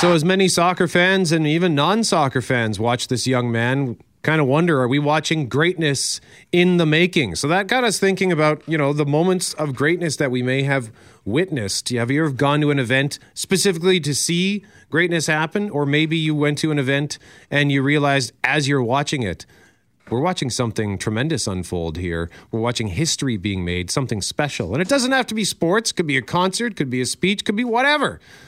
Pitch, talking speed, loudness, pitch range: 150 Hz, 205 wpm, -19 LUFS, 125-175 Hz